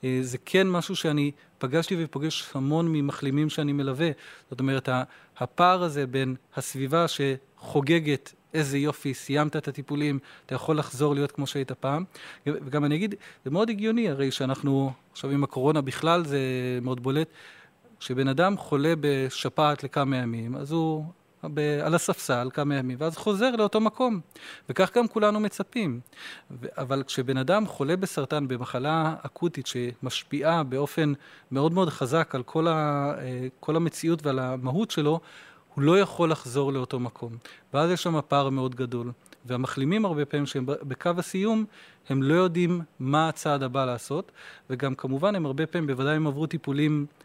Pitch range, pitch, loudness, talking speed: 135-165 Hz, 145 Hz, -27 LUFS, 150 wpm